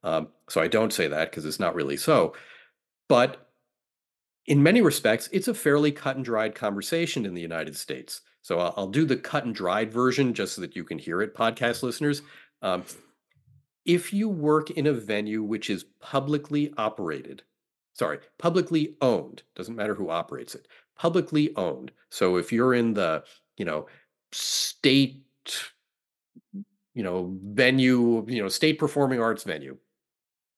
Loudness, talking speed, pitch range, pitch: -26 LUFS, 160 wpm, 110-150 Hz, 130 Hz